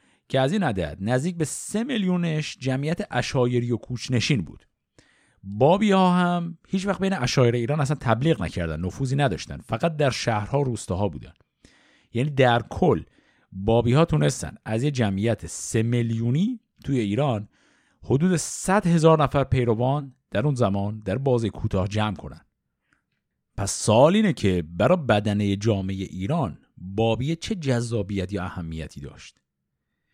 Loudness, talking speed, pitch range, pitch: -24 LUFS, 145 wpm, 100-150 Hz, 120 Hz